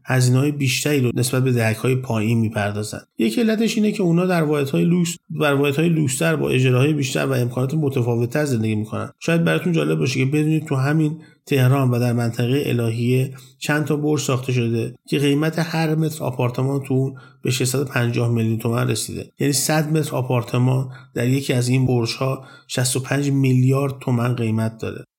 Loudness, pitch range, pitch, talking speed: -20 LUFS, 125-150 Hz, 135 Hz, 170 wpm